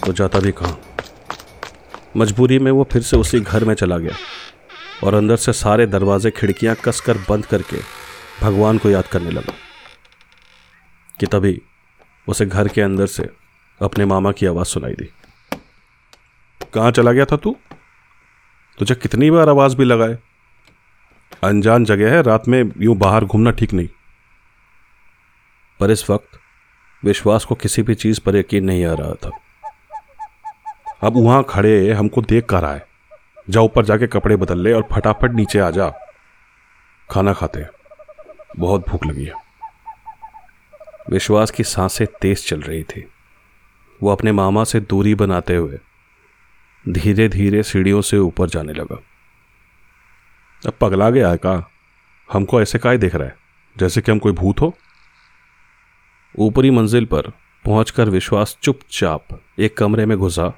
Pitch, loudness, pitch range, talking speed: 110 Hz, -16 LUFS, 100-120 Hz, 145 wpm